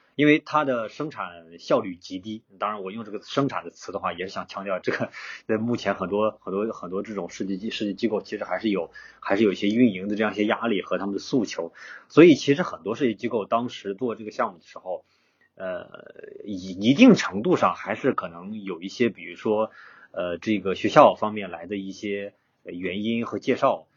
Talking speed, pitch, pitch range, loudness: 315 characters per minute, 110 Hz, 100-120 Hz, -24 LUFS